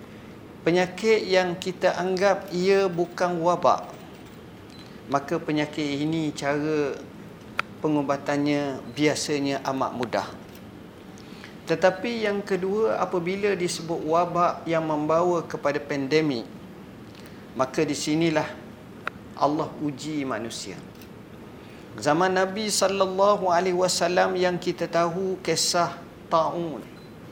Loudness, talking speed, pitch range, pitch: -25 LUFS, 90 wpm, 150-185 Hz, 170 Hz